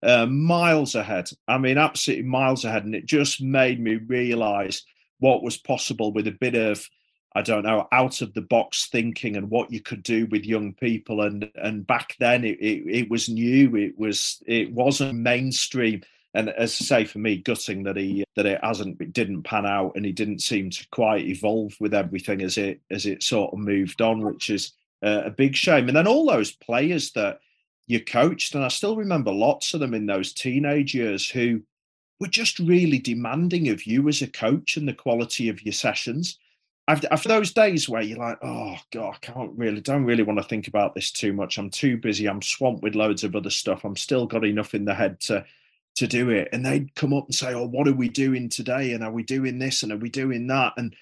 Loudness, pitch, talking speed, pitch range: -23 LUFS, 115 Hz, 220 wpm, 105-135 Hz